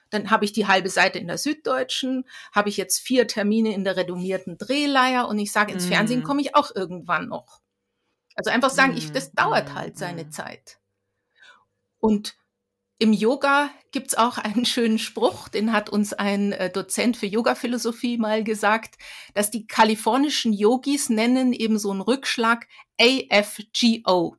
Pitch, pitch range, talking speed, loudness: 220 Hz, 205-245 Hz, 160 wpm, -22 LUFS